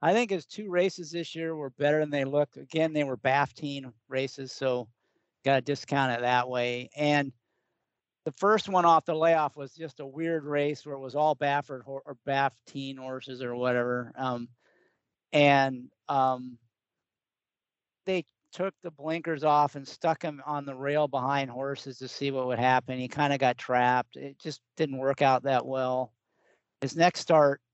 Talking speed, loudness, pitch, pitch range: 180 wpm, -28 LUFS, 140 Hz, 130-150 Hz